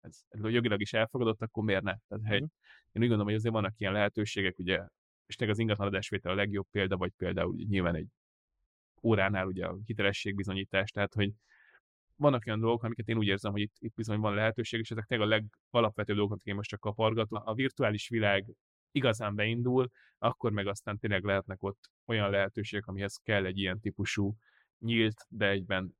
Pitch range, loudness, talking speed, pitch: 100-110 Hz, -32 LUFS, 185 wpm, 105 Hz